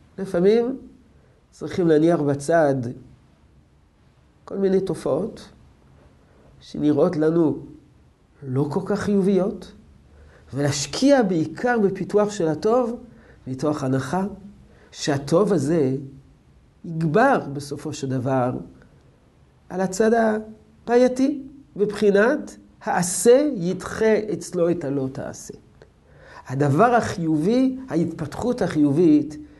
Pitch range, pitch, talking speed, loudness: 140-210 Hz, 170 Hz, 80 wpm, -21 LUFS